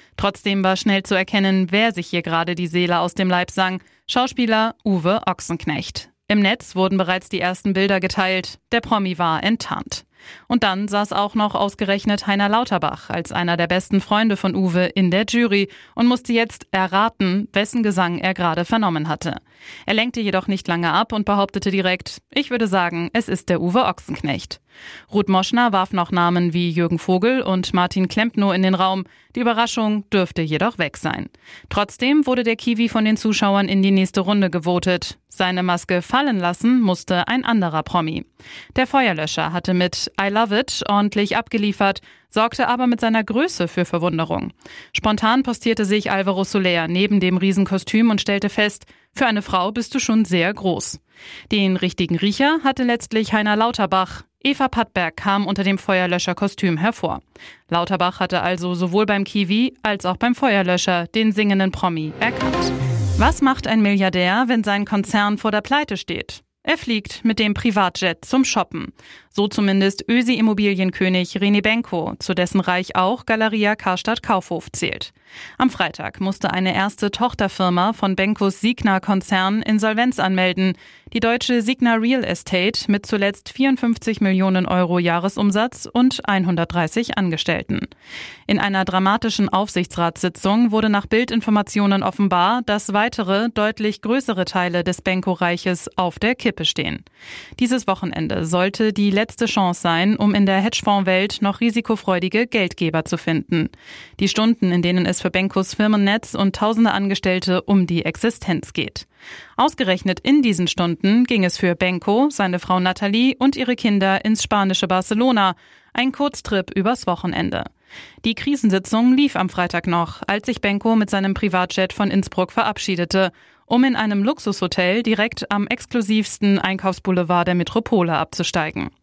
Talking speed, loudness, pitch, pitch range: 155 wpm, -19 LUFS, 200 Hz, 185-220 Hz